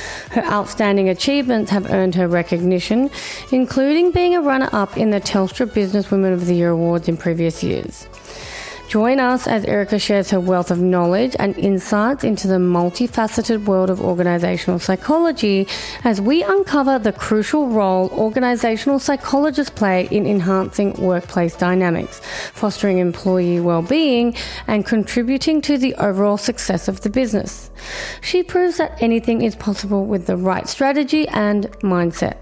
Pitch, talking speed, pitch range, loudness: 205 Hz, 145 wpm, 185-250 Hz, -18 LUFS